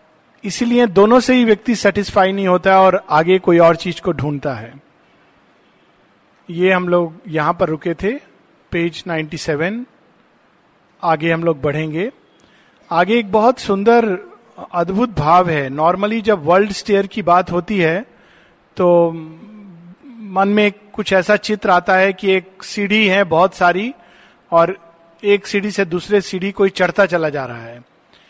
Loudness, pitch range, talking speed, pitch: -15 LUFS, 170-205 Hz, 150 wpm, 185 Hz